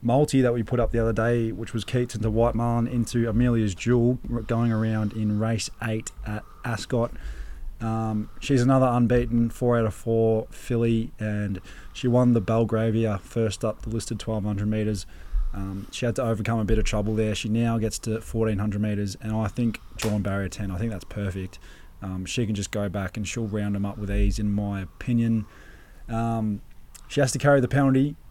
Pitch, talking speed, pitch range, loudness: 110 Hz, 200 wpm, 105-115 Hz, -25 LUFS